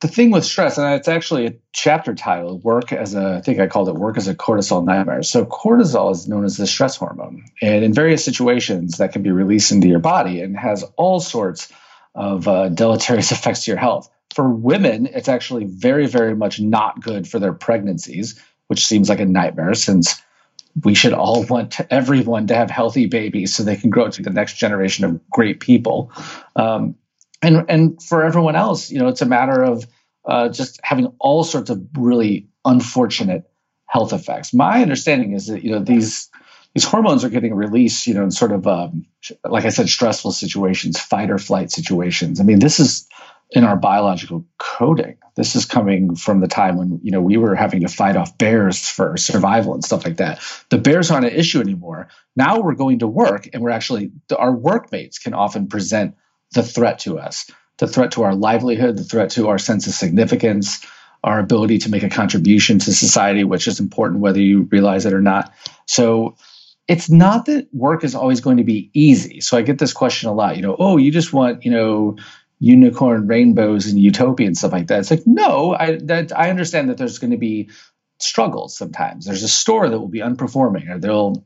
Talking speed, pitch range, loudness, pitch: 205 wpm, 100-160 Hz, -16 LUFS, 115 Hz